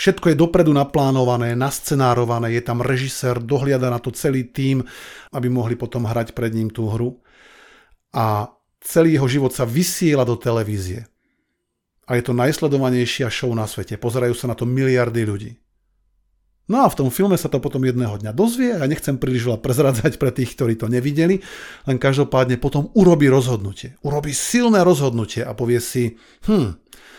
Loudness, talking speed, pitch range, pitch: -19 LUFS, 170 wpm, 120-140 Hz, 125 Hz